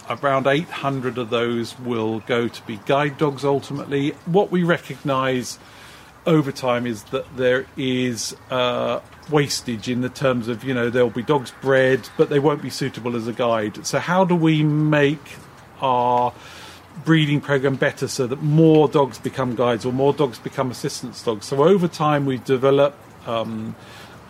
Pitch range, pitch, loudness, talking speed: 120-145 Hz, 130 Hz, -21 LUFS, 165 wpm